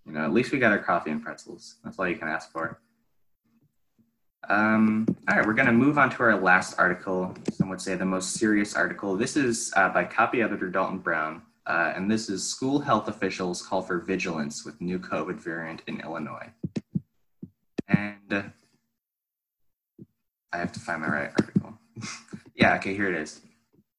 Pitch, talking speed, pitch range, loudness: 95 Hz, 185 wpm, 90-110 Hz, -26 LUFS